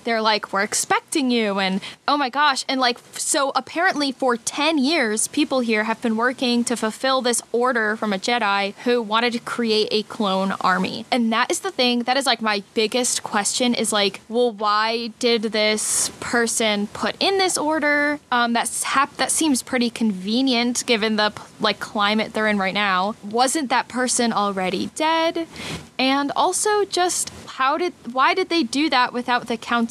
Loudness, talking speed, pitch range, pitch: -20 LUFS, 180 wpm, 215-275 Hz, 240 Hz